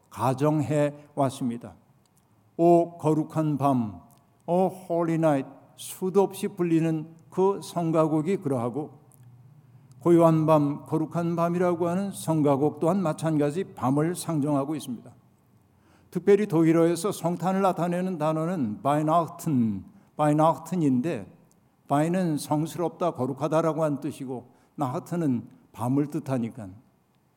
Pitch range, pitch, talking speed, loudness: 140-170 Hz, 155 Hz, 270 characters per minute, -26 LUFS